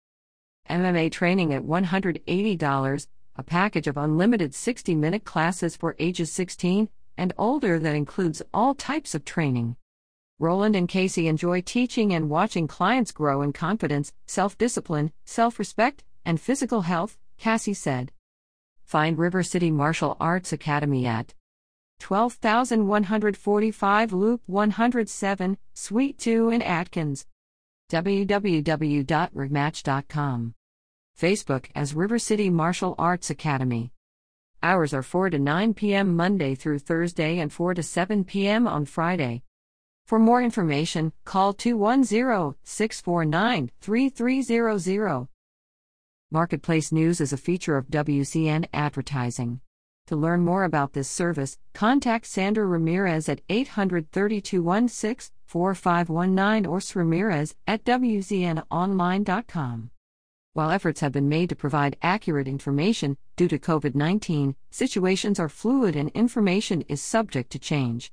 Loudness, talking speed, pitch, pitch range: -25 LUFS, 115 wpm, 170 Hz, 145-205 Hz